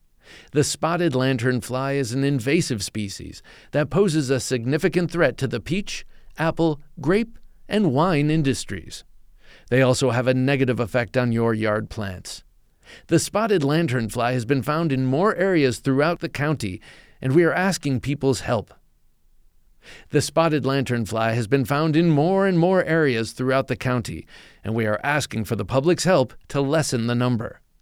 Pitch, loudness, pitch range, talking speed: 135 Hz, -22 LUFS, 120-160 Hz, 165 wpm